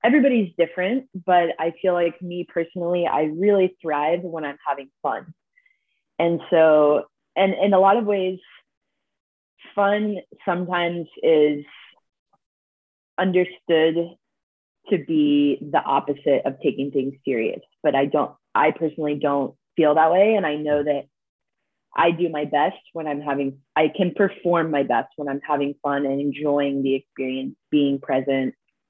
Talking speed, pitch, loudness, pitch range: 145 wpm, 160 Hz, -22 LUFS, 145-180 Hz